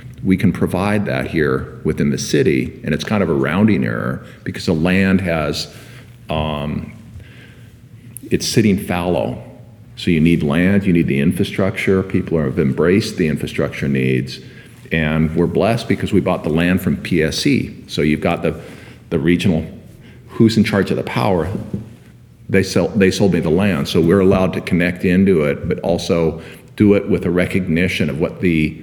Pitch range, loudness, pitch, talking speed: 80-105 Hz, -17 LUFS, 95 Hz, 175 wpm